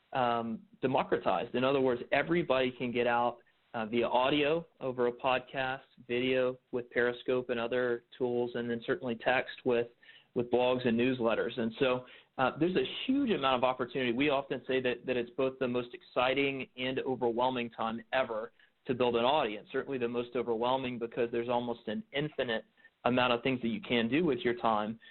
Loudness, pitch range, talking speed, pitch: -32 LUFS, 120-130 Hz, 180 wpm, 125 Hz